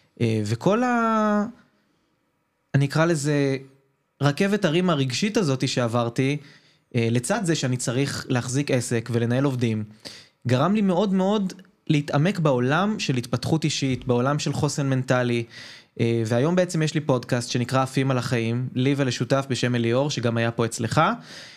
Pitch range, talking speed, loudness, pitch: 125-160 Hz, 135 wpm, -23 LUFS, 135 Hz